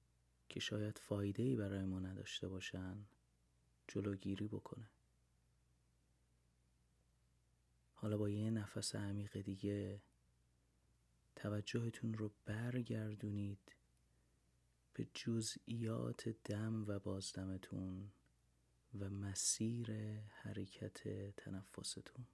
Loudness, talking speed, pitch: -45 LUFS, 75 wpm, 100 Hz